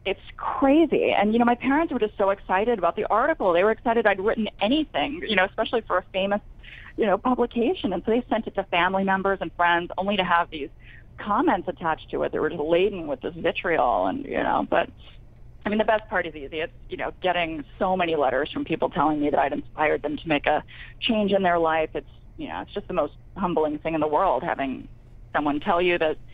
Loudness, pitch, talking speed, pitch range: -24 LUFS, 190 Hz, 235 wpm, 160-220 Hz